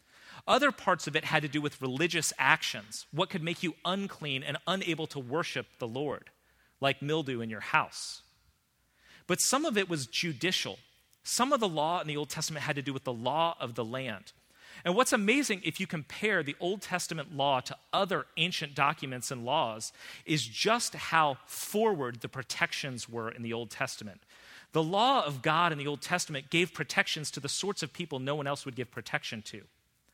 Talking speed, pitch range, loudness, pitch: 195 wpm, 135-175 Hz, -31 LUFS, 155 Hz